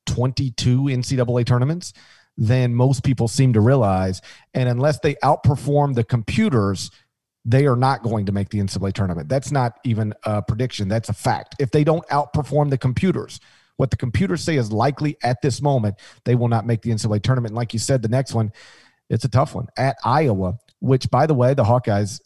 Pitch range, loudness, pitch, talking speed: 115-135 Hz, -20 LUFS, 125 Hz, 195 wpm